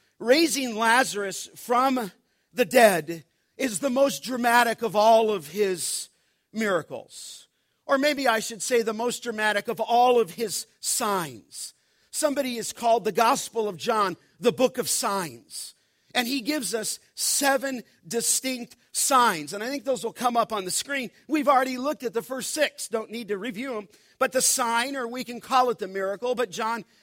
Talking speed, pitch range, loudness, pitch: 175 wpm, 220-255 Hz, -25 LUFS, 235 Hz